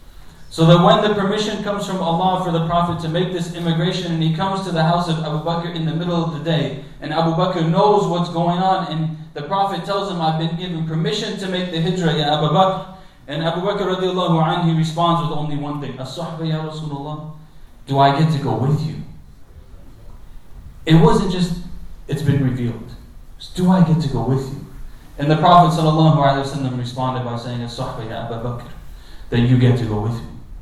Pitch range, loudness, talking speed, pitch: 135-175 Hz, -19 LUFS, 205 wpm, 160 Hz